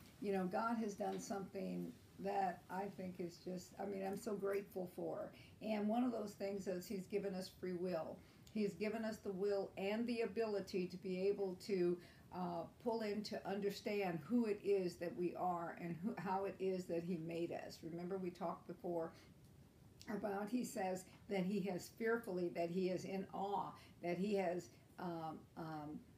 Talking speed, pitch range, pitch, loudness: 185 wpm, 180-205 Hz, 190 Hz, -44 LUFS